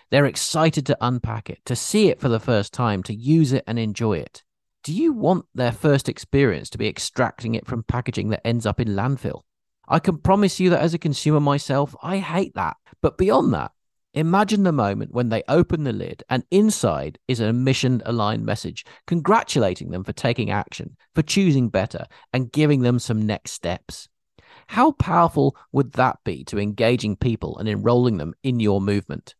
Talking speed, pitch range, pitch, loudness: 190 wpm, 110-155 Hz, 125 Hz, -22 LUFS